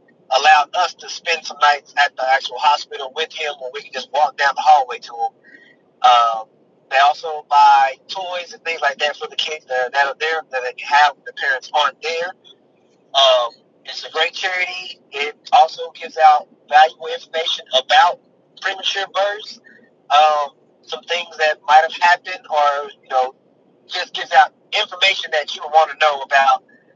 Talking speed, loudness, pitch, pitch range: 175 wpm, -17 LUFS, 160 Hz, 145-195 Hz